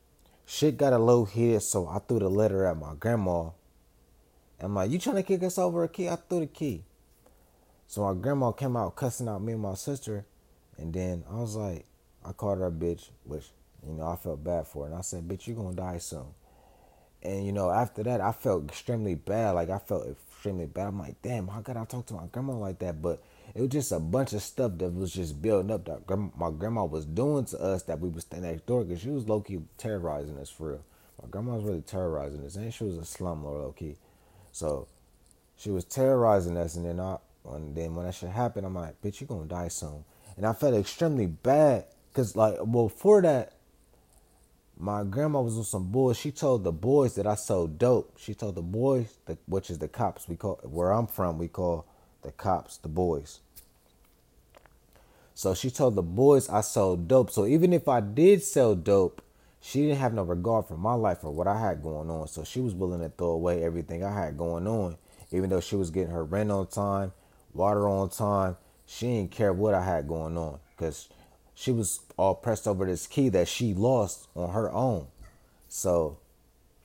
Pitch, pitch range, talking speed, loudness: 95 Hz, 85-115 Hz, 220 wpm, -29 LUFS